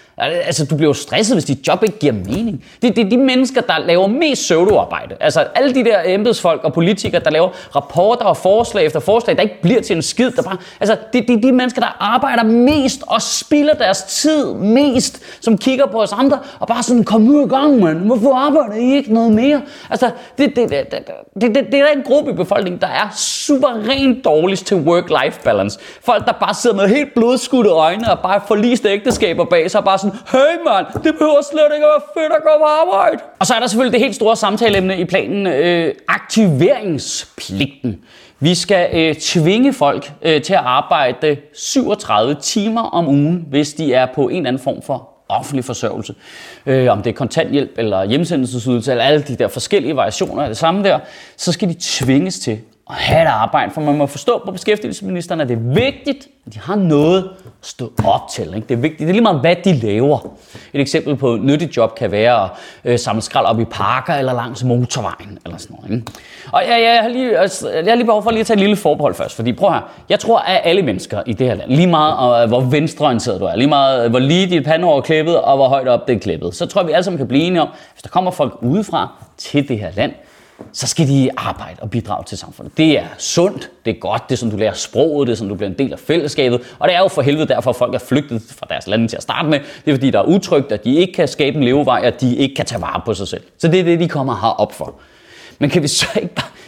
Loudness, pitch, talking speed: -15 LUFS, 175 Hz, 240 wpm